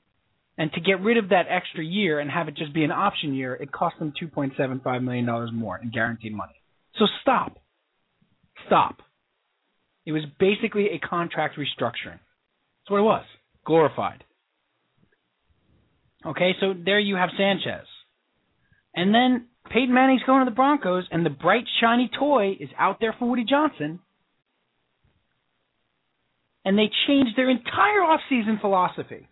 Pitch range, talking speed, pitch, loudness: 155-230 Hz, 145 wpm, 190 Hz, -23 LUFS